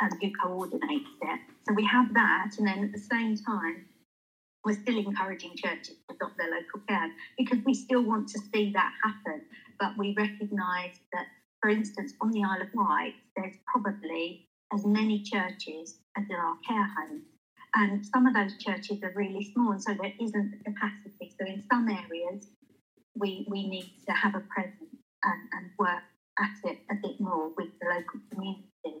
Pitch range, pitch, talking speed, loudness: 190-225 Hz, 205 Hz, 185 wpm, -31 LUFS